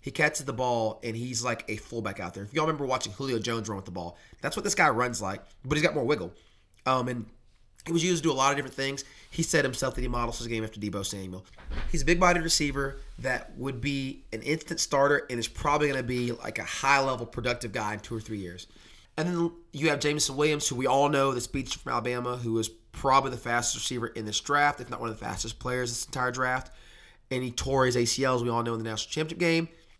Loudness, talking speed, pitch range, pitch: -28 LUFS, 260 wpm, 115-140 Hz, 125 Hz